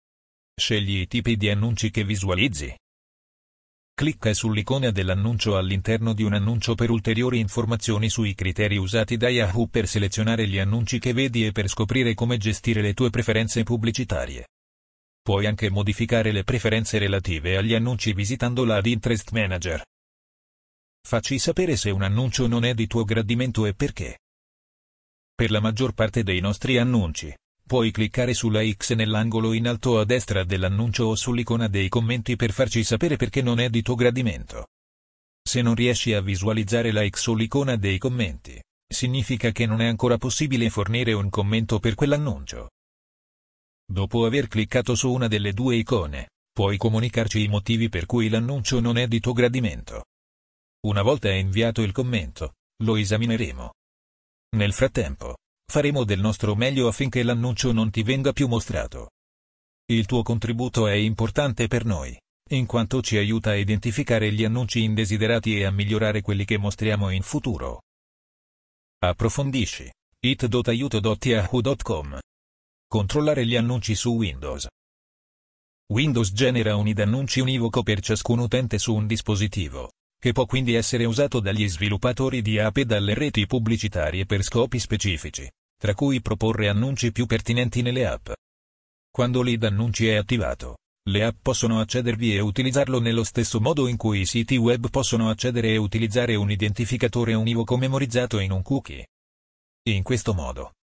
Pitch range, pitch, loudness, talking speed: 100-120 Hz, 110 Hz, -23 LUFS, 150 wpm